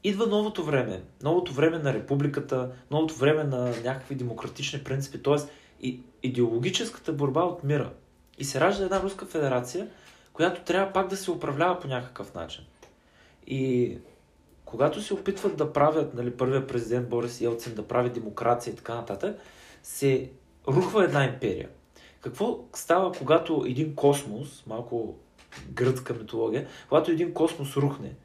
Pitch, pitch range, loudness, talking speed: 140 Hz, 125-160 Hz, -28 LUFS, 140 wpm